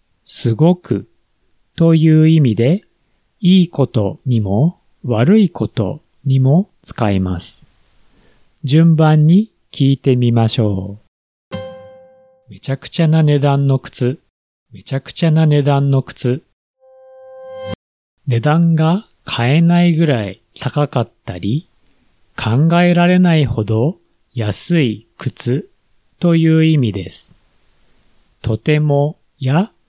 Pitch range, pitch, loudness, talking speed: 115-165 Hz, 145 Hz, -15 LUFS, 190 characters per minute